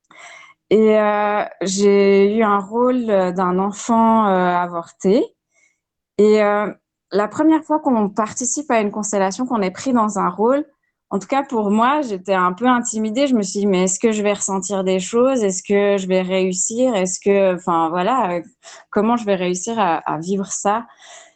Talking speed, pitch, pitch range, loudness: 180 wpm, 205 Hz, 190-235 Hz, -18 LUFS